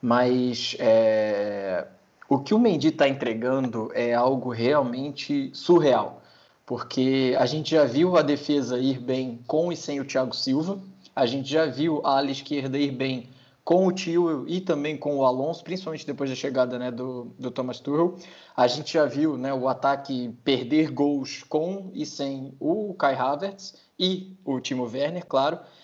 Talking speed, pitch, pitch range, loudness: 170 wpm, 140 Hz, 130-160 Hz, -25 LUFS